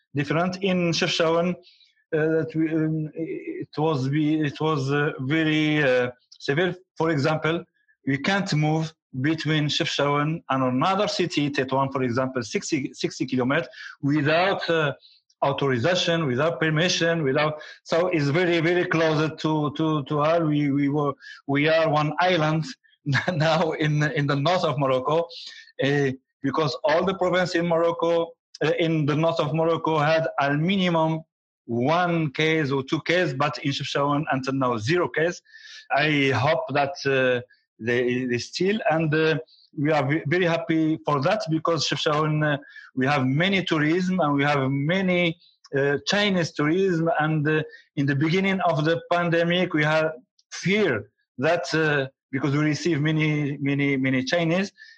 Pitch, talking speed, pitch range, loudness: 155 Hz, 145 wpm, 145-170 Hz, -23 LUFS